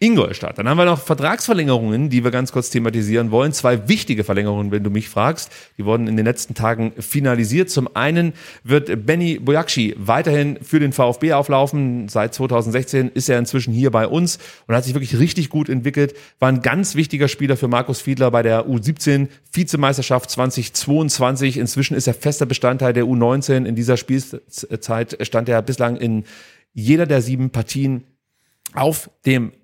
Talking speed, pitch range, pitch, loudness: 170 wpm, 120-145 Hz, 130 Hz, -18 LUFS